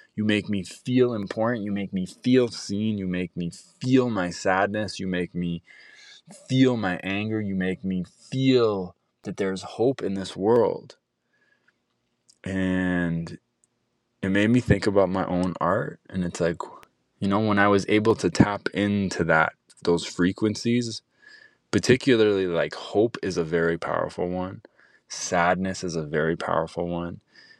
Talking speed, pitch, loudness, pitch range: 150 wpm, 95 Hz, -25 LUFS, 90-110 Hz